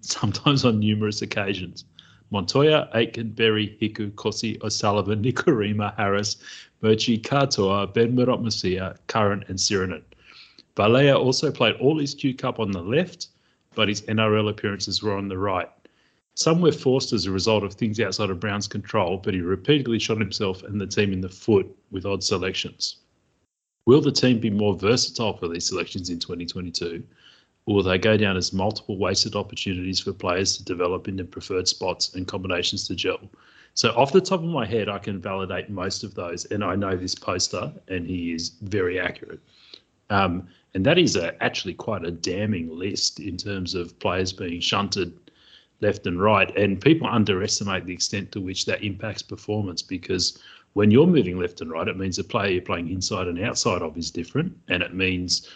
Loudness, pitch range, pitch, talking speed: -23 LUFS, 95-110 Hz, 100 Hz, 185 wpm